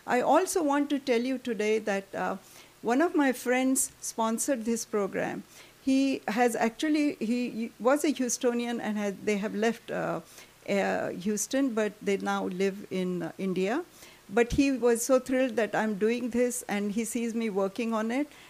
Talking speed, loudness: 175 wpm, -29 LUFS